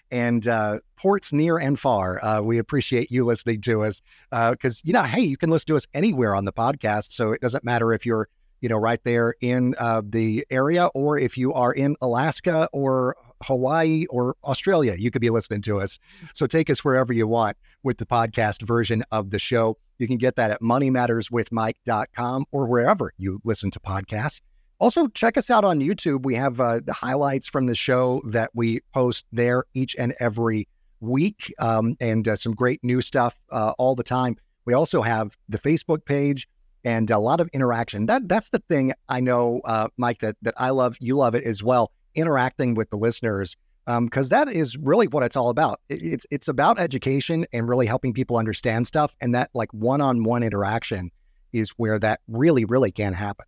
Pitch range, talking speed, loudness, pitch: 115-135 Hz, 200 wpm, -23 LUFS, 120 Hz